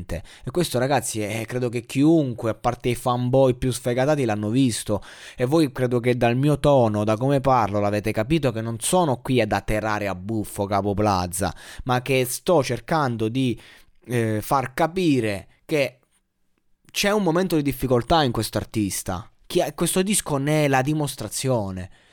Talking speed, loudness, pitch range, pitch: 165 wpm, -22 LUFS, 105-140 Hz, 125 Hz